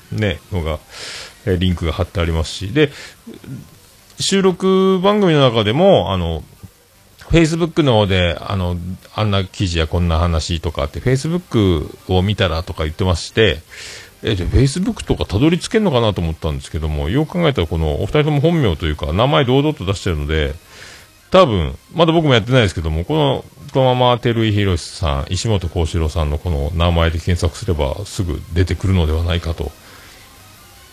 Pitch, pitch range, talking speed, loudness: 95 Hz, 85-130 Hz, 360 characters per minute, -17 LUFS